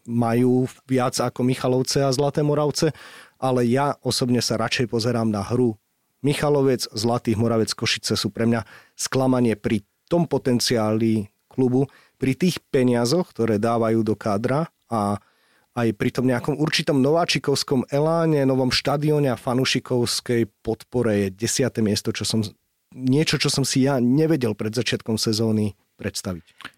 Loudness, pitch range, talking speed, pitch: -22 LUFS, 115-135 Hz, 140 wpm, 125 Hz